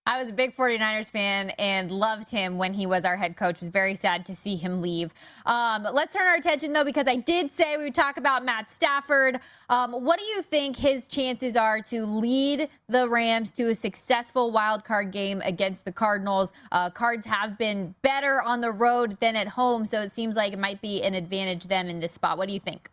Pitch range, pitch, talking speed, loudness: 195-255 Hz, 220 Hz, 230 wpm, -25 LUFS